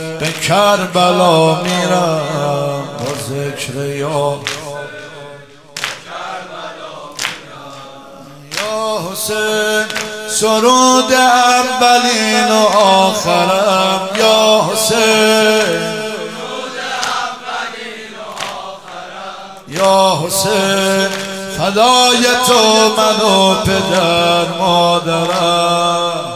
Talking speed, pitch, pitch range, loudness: 50 wpm, 195 Hz, 165-220 Hz, -12 LUFS